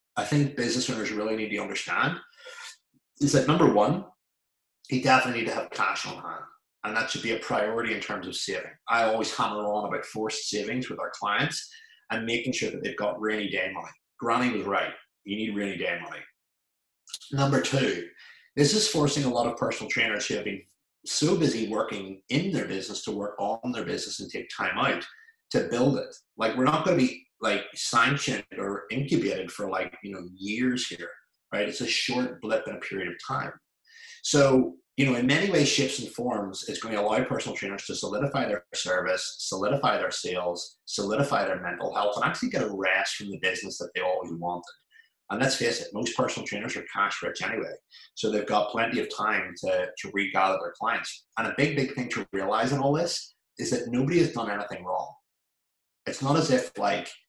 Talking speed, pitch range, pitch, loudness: 205 wpm, 105-150 Hz, 125 Hz, -27 LUFS